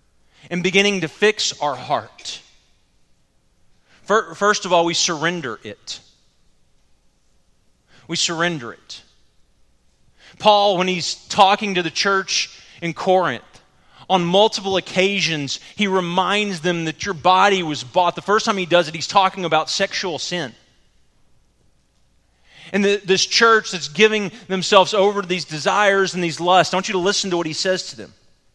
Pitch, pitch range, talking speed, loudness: 180 Hz, 155-195 Hz, 150 wpm, -18 LUFS